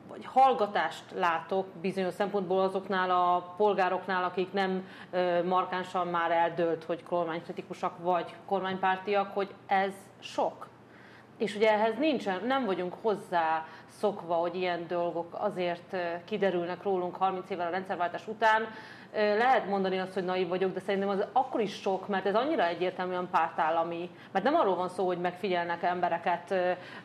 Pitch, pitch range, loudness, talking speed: 185 Hz, 175-200 Hz, -30 LUFS, 140 wpm